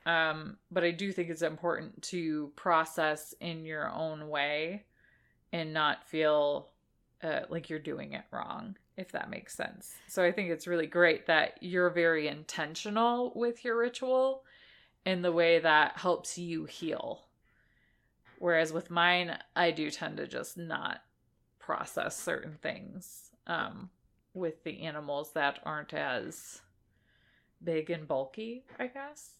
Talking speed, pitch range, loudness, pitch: 145 wpm, 155-185 Hz, -32 LUFS, 170 Hz